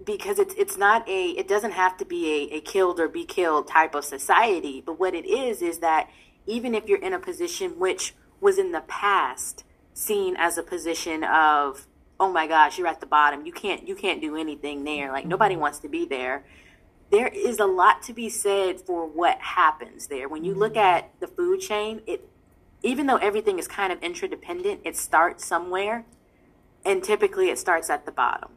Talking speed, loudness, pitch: 205 wpm, -24 LUFS, 220 Hz